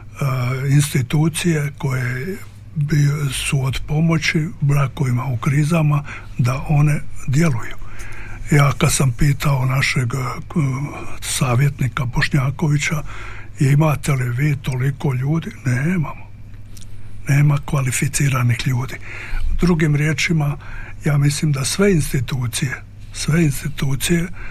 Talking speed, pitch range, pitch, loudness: 90 wpm, 120-150 Hz, 140 Hz, -19 LUFS